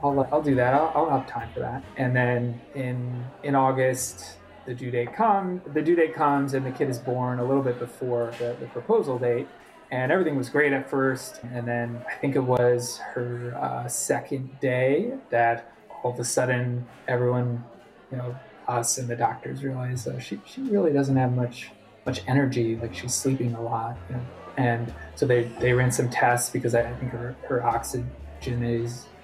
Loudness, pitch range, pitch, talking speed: -26 LUFS, 120-130 Hz, 125 Hz, 195 wpm